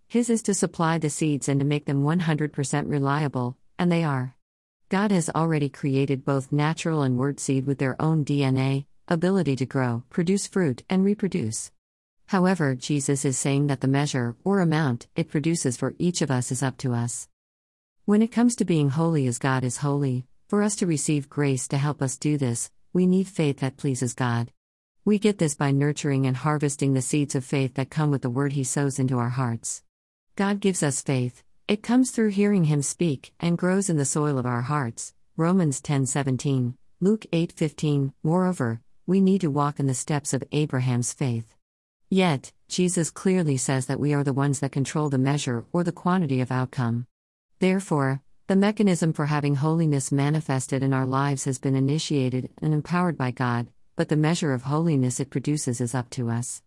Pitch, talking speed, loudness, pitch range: 140 Hz, 190 wpm, -25 LUFS, 130-165 Hz